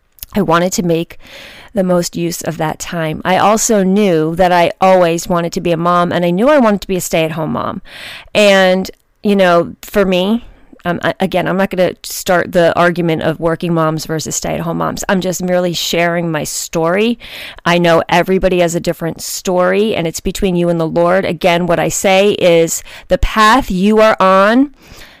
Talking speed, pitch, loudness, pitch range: 195 wpm, 180 Hz, -13 LUFS, 170-195 Hz